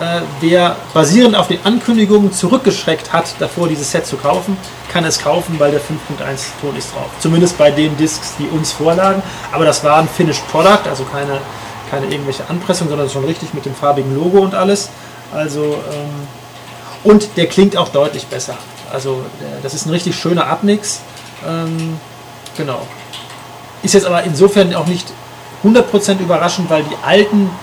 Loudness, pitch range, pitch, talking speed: -14 LUFS, 140-180 Hz, 160 Hz, 165 wpm